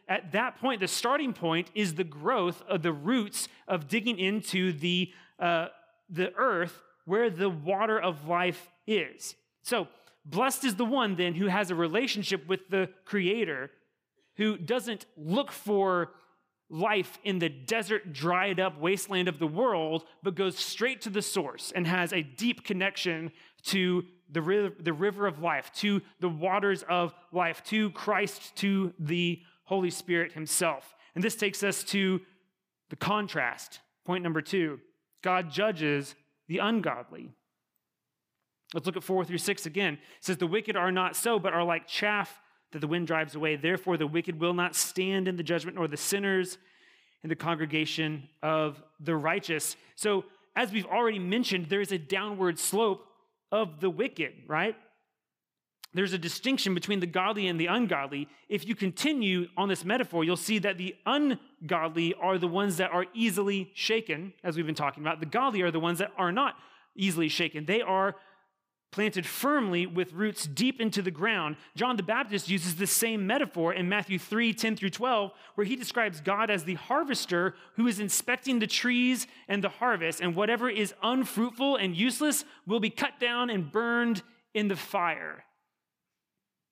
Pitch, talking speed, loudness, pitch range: 190 Hz, 170 wpm, -30 LUFS, 175-215 Hz